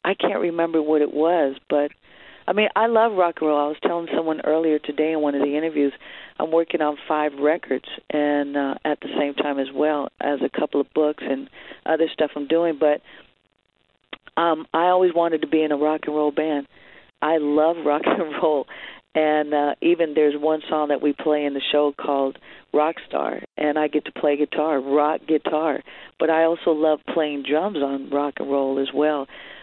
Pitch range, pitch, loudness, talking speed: 145-160 Hz, 150 Hz, -22 LUFS, 205 wpm